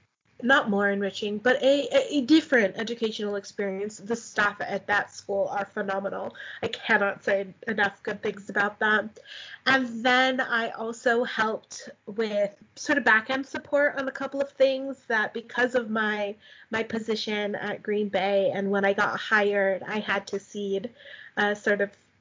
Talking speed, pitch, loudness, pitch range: 170 wpm, 215 Hz, -26 LUFS, 200-245 Hz